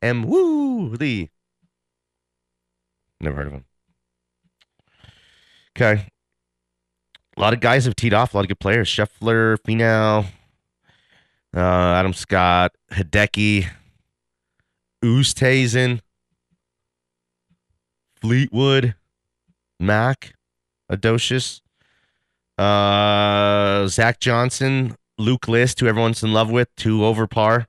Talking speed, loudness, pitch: 90 wpm, -19 LUFS, 105 Hz